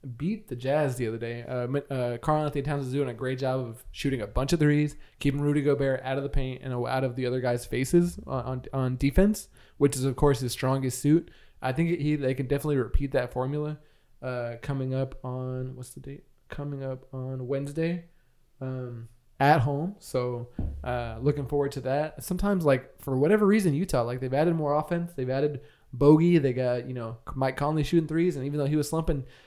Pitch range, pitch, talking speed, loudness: 130-150 Hz, 135 Hz, 210 wpm, -28 LUFS